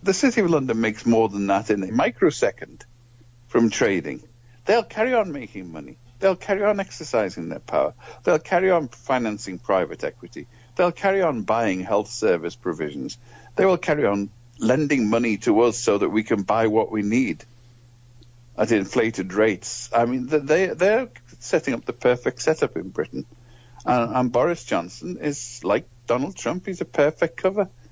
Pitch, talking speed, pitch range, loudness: 120 Hz, 165 wpm, 115-160 Hz, -22 LUFS